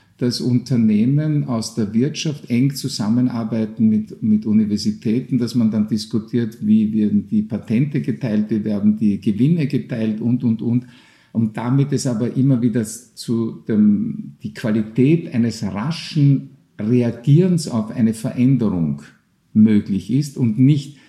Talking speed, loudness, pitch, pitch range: 135 wpm, -19 LUFS, 120 Hz, 110-135 Hz